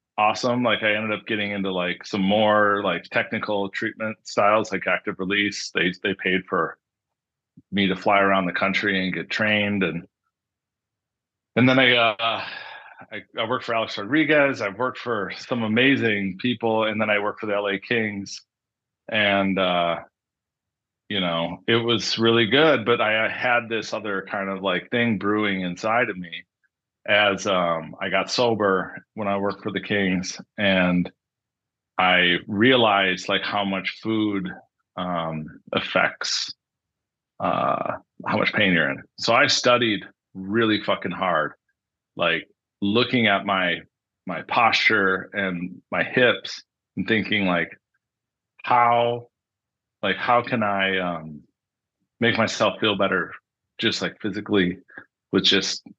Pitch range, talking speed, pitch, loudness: 95-115 Hz, 145 wpm, 105 Hz, -22 LUFS